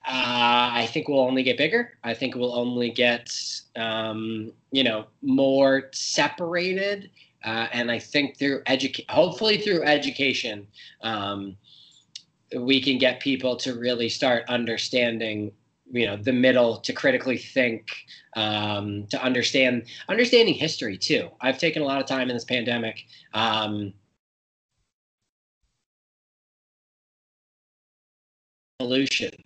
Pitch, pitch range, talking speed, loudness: 125 Hz, 115-135 Hz, 120 wpm, -24 LUFS